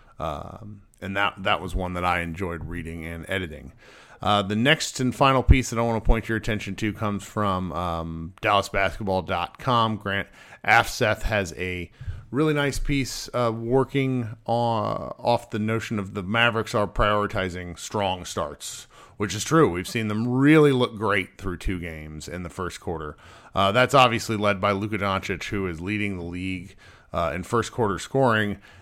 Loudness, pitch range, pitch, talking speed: -24 LUFS, 95-115 Hz, 105 Hz, 175 wpm